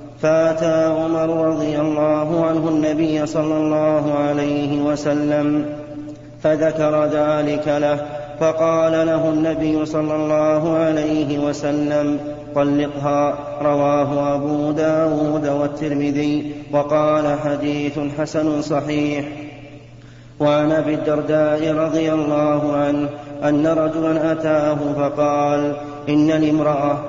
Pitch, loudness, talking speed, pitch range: 150 Hz, -19 LUFS, 90 wpm, 145-155 Hz